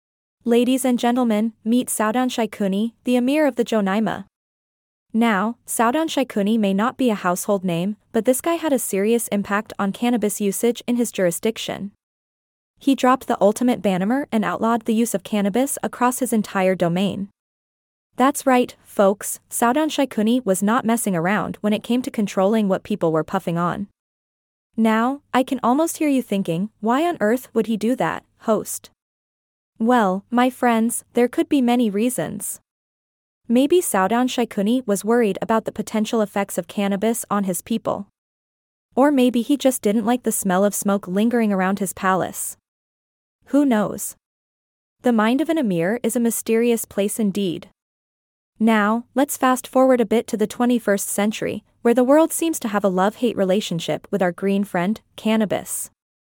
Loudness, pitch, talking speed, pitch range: -20 LUFS, 225 Hz, 165 wpm, 200-245 Hz